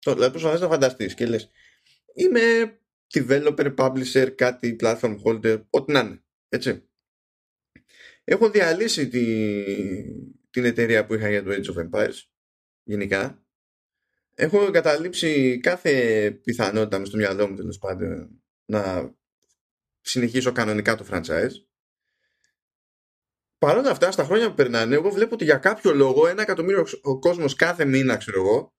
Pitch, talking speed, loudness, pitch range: 125 Hz, 135 wpm, -22 LUFS, 110-170 Hz